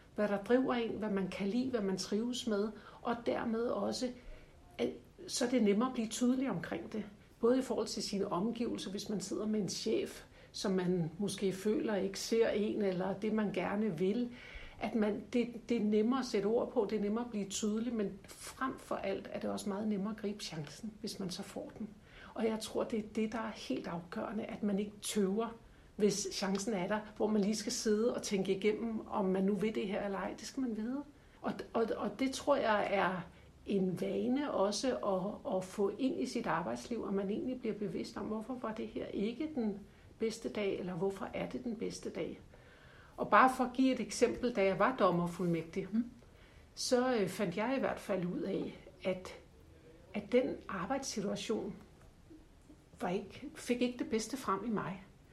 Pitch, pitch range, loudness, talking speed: 215 Hz, 200-235 Hz, -36 LUFS, 205 wpm